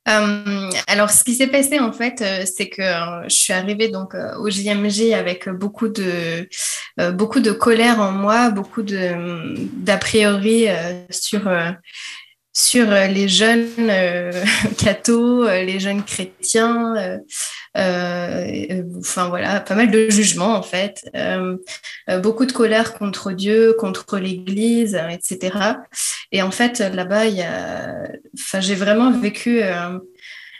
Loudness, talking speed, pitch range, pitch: -18 LUFS, 140 wpm, 185-225 Hz, 205 Hz